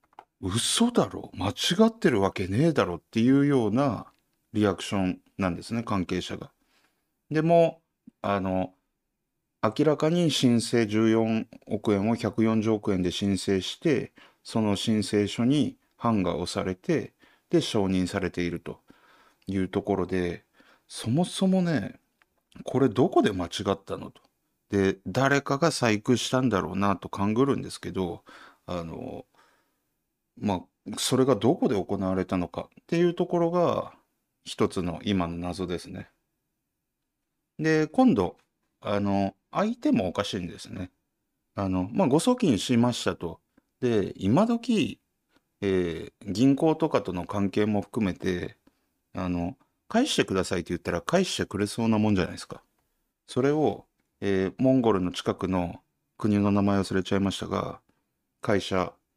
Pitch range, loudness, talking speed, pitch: 95-135 Hz, -26 LUFS, 265 characters per minute, 105 Hz